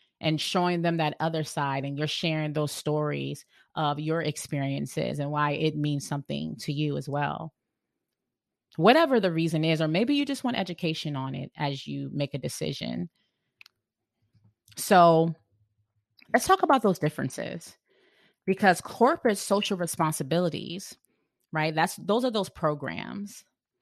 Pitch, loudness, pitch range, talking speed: 155 Hz, -27 LUFS, 140-180 Hz, 140 wpm